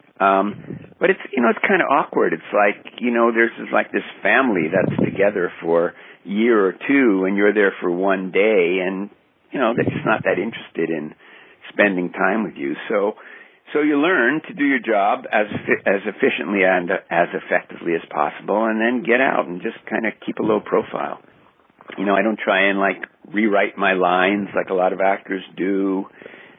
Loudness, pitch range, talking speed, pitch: -19 LUFS, 95-115 Hz, 195 wpm, 100 Hz